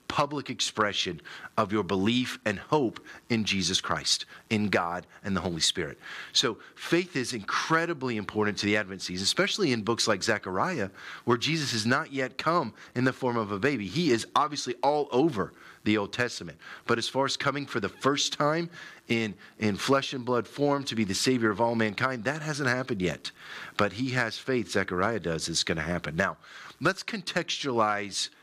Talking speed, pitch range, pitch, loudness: 190 wpm, 105-140 Hz, 120 Hz, -28 LUFS